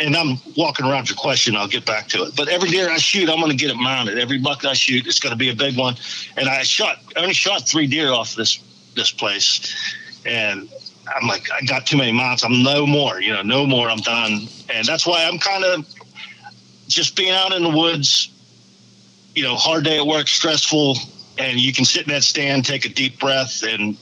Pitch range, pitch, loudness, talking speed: 125-160 Hz, 135 Hz, -17 LUFS, 230 wpm